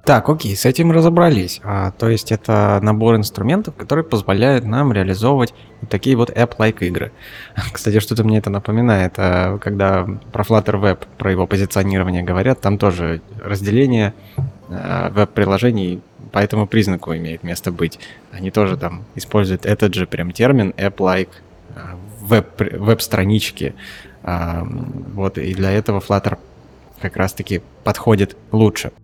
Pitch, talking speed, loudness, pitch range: 105 Hz, 135 wpm, -17 LUFS, 95-115 Hz